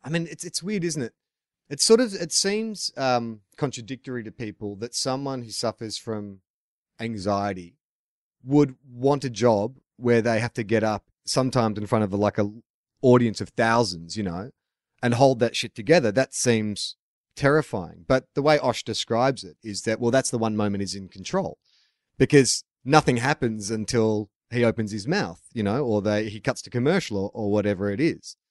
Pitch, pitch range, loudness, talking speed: 115 Hz, 105-130 Hz, -24 LUFS, 185 wpm